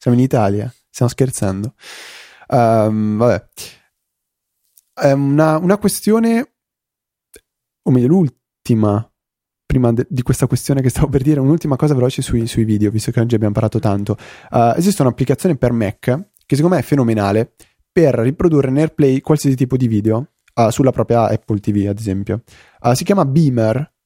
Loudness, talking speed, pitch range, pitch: -16 LUFS, 155 wpm, 110-145 Hz, 125 Hz